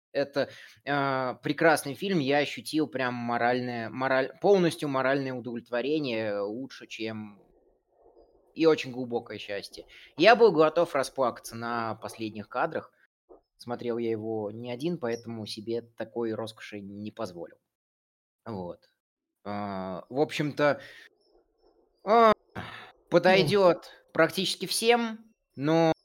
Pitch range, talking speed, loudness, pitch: 115-165 Hz, 105 wpm, -27 LUFS, 130 Hz